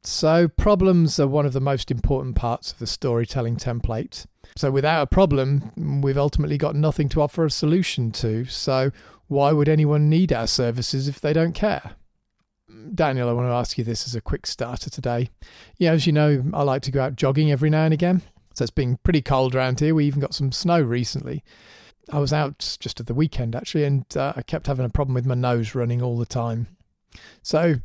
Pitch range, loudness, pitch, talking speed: 125-155 Hz, -22 LUFS, 140 Hz, 215 wpm